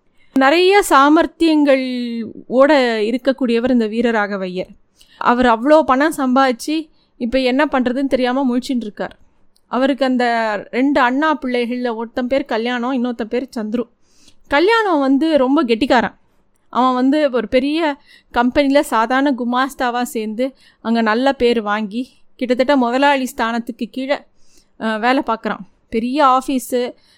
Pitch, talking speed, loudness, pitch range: 255 Hz, 115 wpm, -16 LUFS, 235-275 Hz